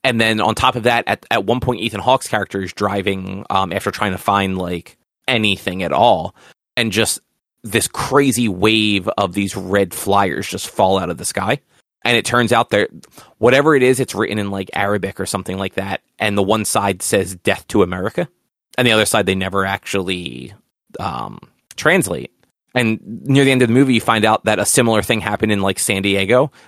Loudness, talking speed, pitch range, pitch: -17 LUFS, 205 wpm, 95-115 Hz, 100 Hz